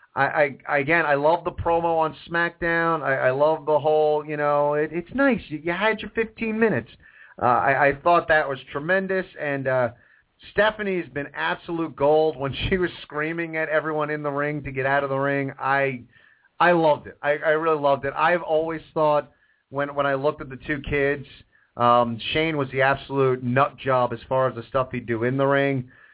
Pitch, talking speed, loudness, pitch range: 145 Hz, 205 wpm, -23 LUFS, 135-165 Hz